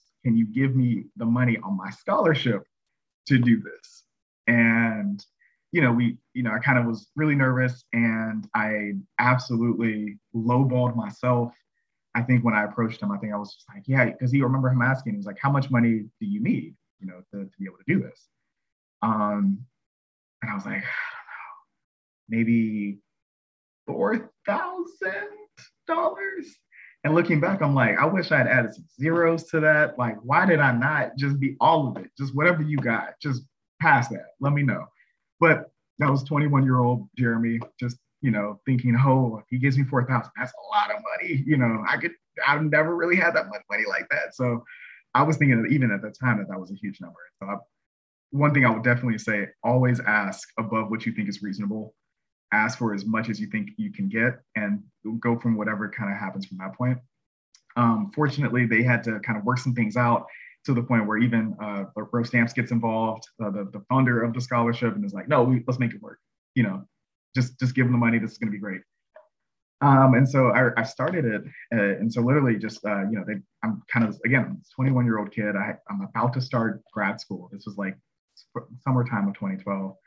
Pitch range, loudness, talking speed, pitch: 110-140 Hz, -24 LUFS, 215 wpm, 120 Hz